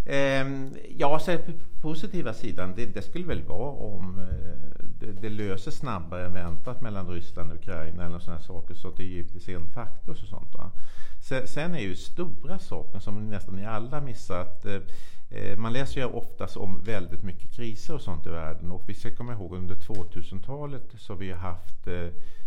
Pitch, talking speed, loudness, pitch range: 100 Hz, 170 wpm, -35 LUFS, 90-120 Hz